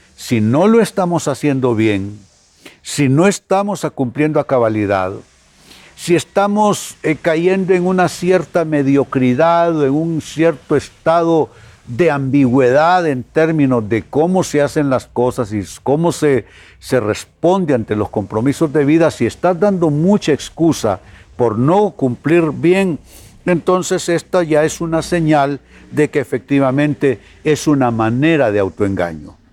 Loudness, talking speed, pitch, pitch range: -15 LUFS, 135 wpm, 145 Hz, 120-170 Hz